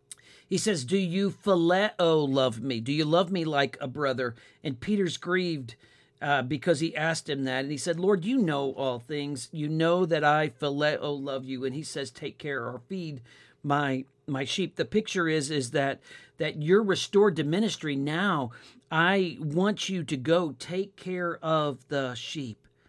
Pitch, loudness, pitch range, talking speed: 150 Hz, -28 LUFS, 135-175 Hz, 180 wpm